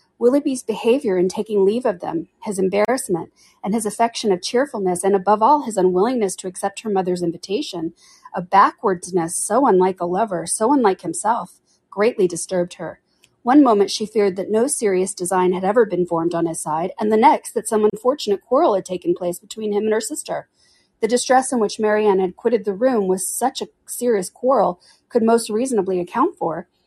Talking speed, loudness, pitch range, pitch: 190 wpm, -19 LUFS, 185-230 Hz, 205 Hz